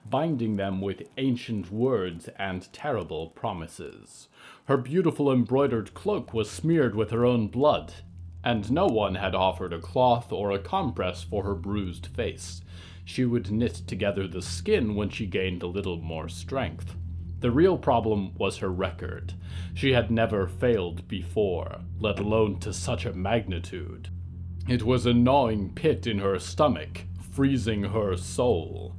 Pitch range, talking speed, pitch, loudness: 90-120 Hz, 150 wpm, 100 Hz, -27 LUFS